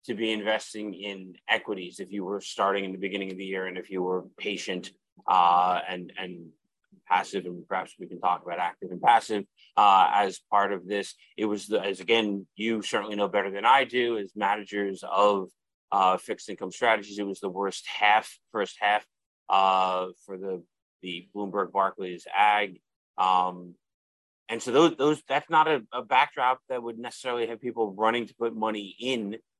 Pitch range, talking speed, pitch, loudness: 95-110 Hz, 185 wpm, 100 Hz, -27 LUFS